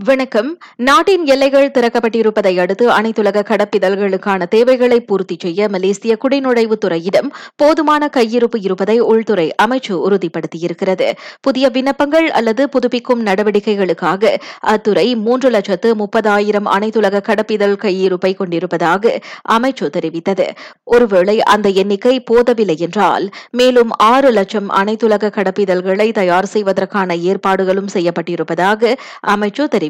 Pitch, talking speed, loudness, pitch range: 210 Hz, 100 wpm, -13 LUFS, 195-245 Hz